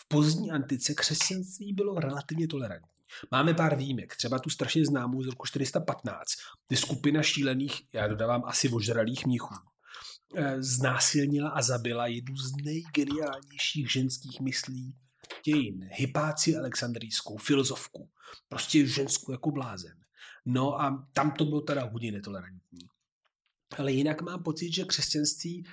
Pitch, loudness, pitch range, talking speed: 140 Hz, -30 LUFS, 125-150 Hz, 130 wpm